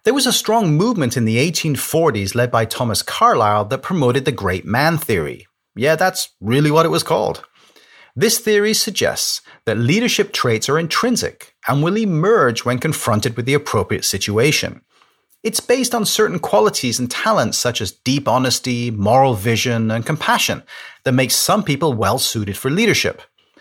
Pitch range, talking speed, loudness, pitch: 115-175 Hz, 165 wpm, -17 LUFS, 135 Hz